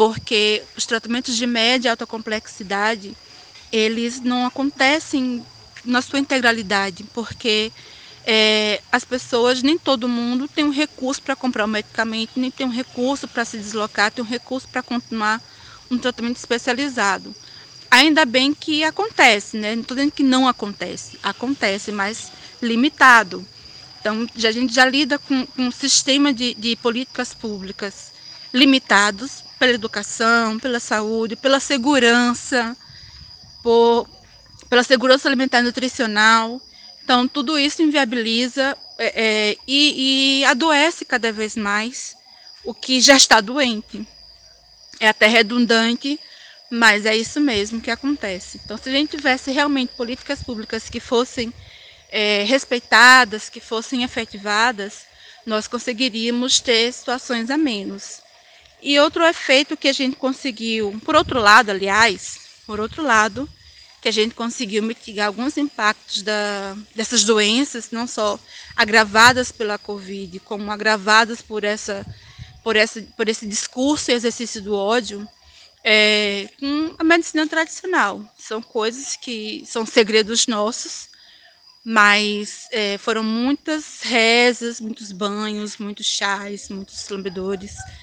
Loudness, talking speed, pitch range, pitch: -18 LUFS, 135 wpm, 215-260 Hz, 235 Hz